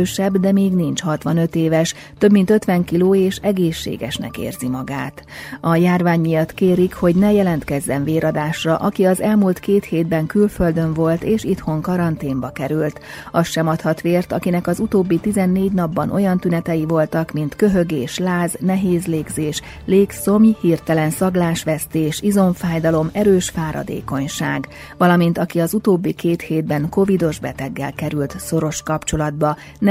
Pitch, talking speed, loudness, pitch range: 170 Hz, 135 wpm, -18 LUFS, 155-190 Hz